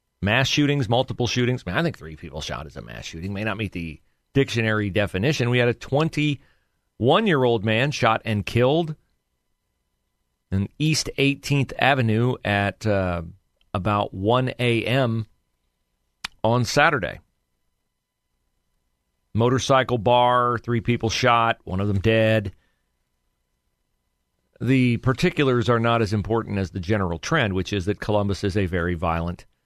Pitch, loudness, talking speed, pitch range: 110 Hz, -22 LUFS, 135 wpm, 85-125 Hz